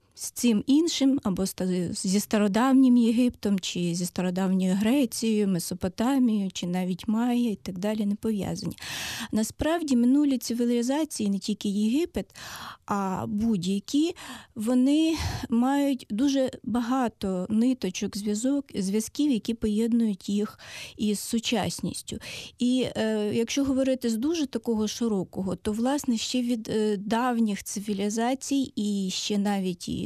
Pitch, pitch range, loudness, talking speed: 225 Hz, 205-255 Hz, -26 LUFS, 115 wpm